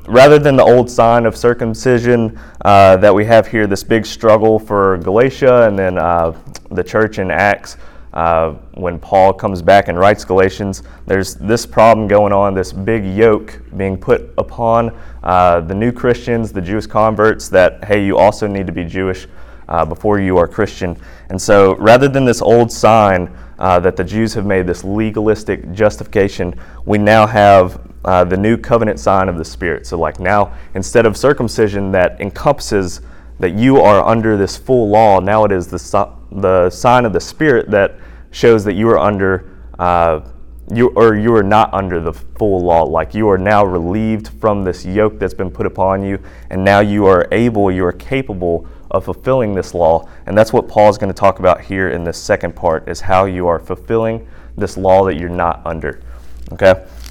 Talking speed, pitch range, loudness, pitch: 190 wpm, 90-110 Hz, -13 LUFS, 100 Hz